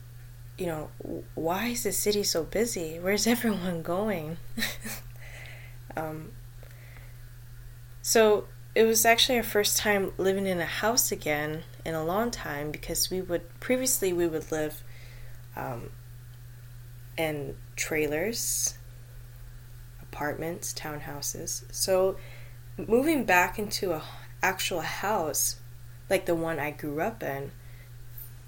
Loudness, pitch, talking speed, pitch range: -28 LUFS, 145 Hz, 115 wpm, 120-175 Hz